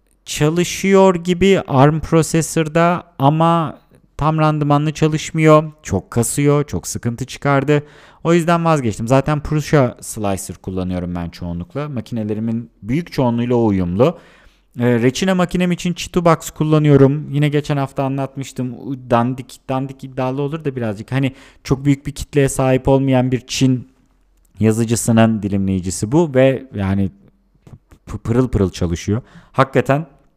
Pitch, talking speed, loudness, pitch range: 135 Hz, 115 wpm, -17 LUFS, 115-150 Hz